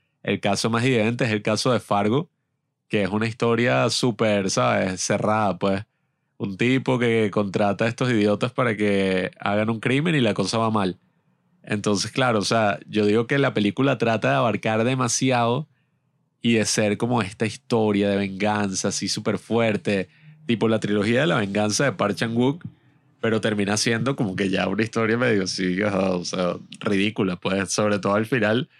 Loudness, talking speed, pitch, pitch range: -22 LUFS, 175 wpm, 110 Hz, 105-130 Hz